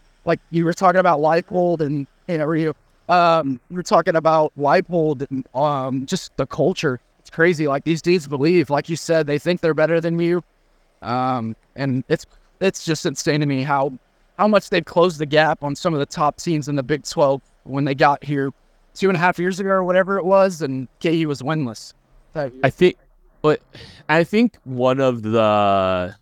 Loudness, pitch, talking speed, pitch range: -19 LUFS, 155 Hz, 195 wpm, 140-175 Hz